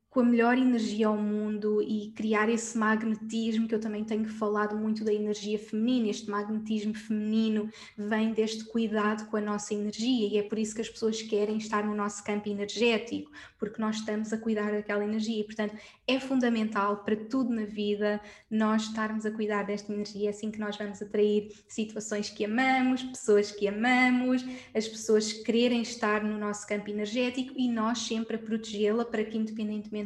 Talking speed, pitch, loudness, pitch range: 180 wpm, 215 Hz, -30 LUFS, 210-225 Hz